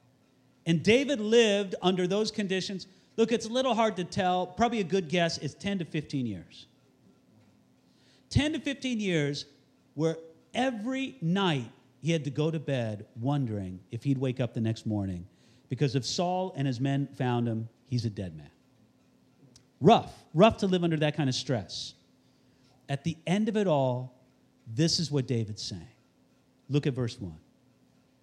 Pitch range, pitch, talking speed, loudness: 125-185 Hz, 145 Hz, 170 wpm, -29 LUFS